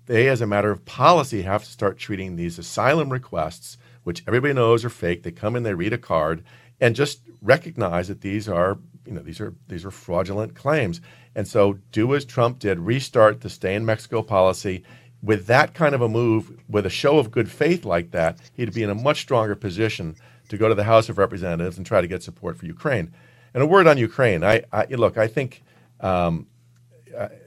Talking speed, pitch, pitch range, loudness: 215 wpm, 110 Hz, 100-125 Hz, -21 LUFS